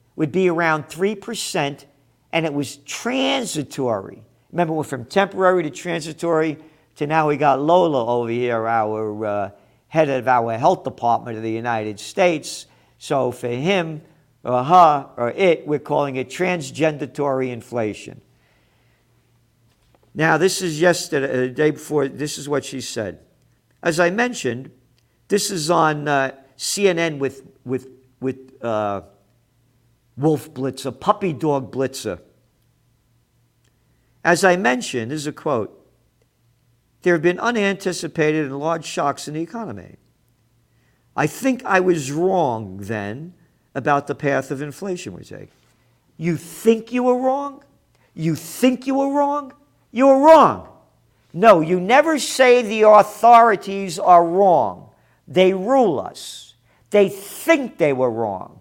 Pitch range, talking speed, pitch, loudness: 125-180 Hz, 135 wpm, 150 Hz, -19 LUFS